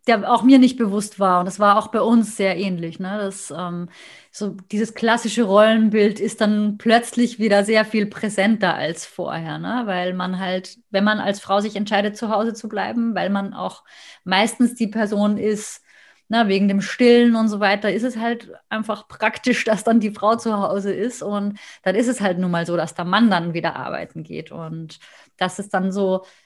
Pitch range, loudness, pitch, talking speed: 190-225 Hz, -20 LUFS, 205 Hz, 205 wpm